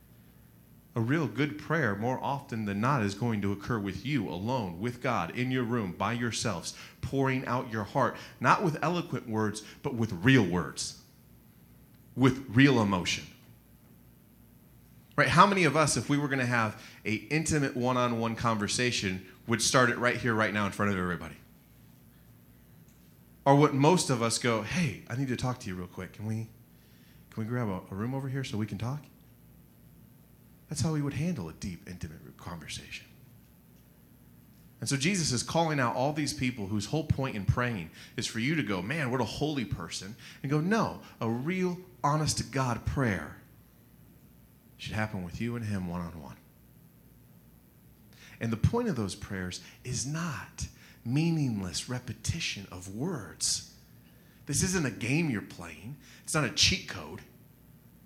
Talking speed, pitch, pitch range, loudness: 170 wpm, 120 Hz, 105-140 Hz, -30 LUFS